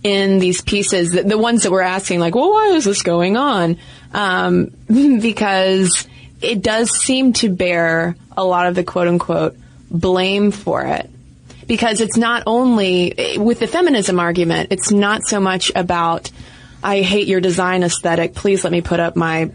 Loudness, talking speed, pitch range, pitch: -16 LUFS, 165 wpm, 175-220 Hz, 190 Hz